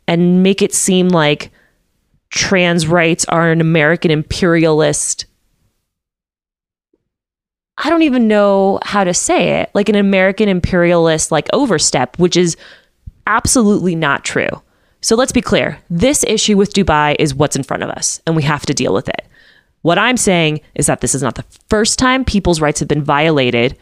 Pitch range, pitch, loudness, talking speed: 150-200 Hz, 170 Hz, -13 LUFS, 170 wpm